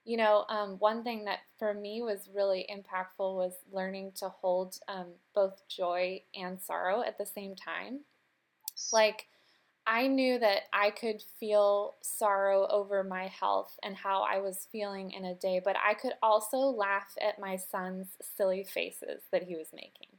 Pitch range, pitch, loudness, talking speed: 190-215 Hz, 200 Hz, -32 LUFS, 170 wpm